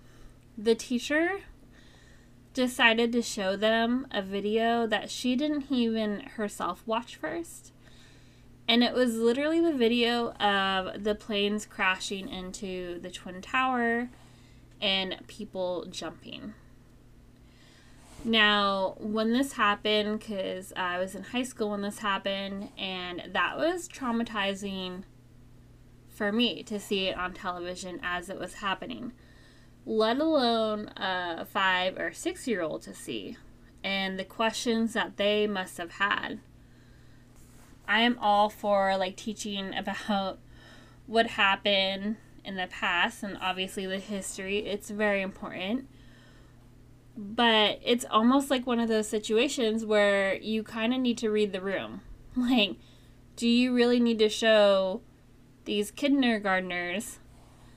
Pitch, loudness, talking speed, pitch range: 205 Hz, -28 LUFS, 125 wpm, 185-230 Hz